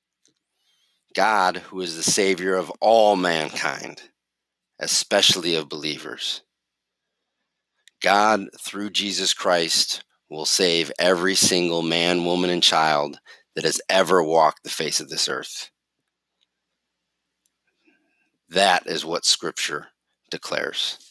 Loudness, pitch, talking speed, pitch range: -21 LUFS, 90 Hz, 105 wpm, 85-105 Hz